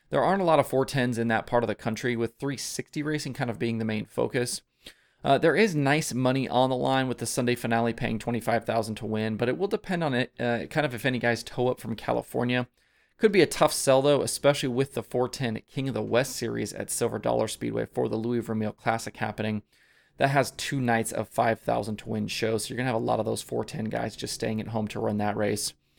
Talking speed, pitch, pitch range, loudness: 245 wpm, 120 Hz, 110-130 Hz, -27 LUFS